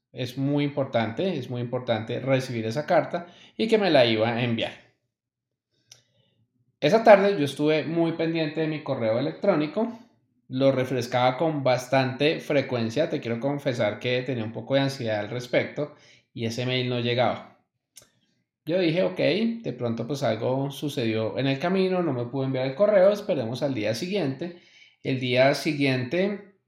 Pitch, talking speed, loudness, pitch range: 135 Hz, 160 wpm, -25 LUFS, 125-155 Hz